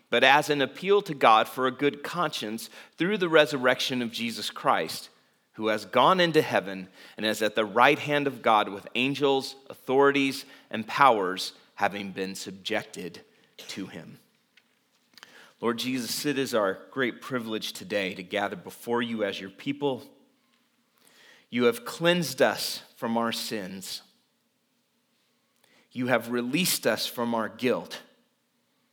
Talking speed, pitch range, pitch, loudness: 140 wpm, 110-145 Hz, 130 Hz, -26 LUFS